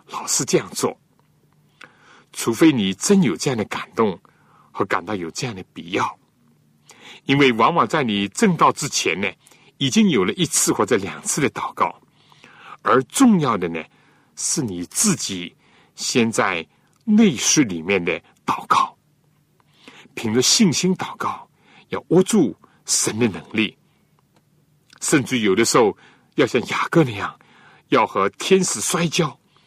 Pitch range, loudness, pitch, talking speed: 120-190 Hz, -19 LUFS, 155 Hz, 195 characters per minute